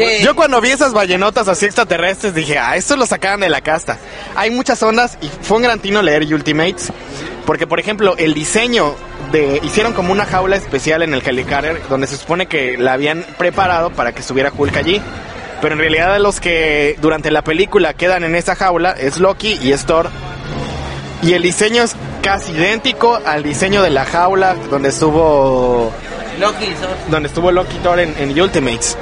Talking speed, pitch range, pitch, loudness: 180 wpm, 145-200 Hz, 170 Hz, -14 LUFS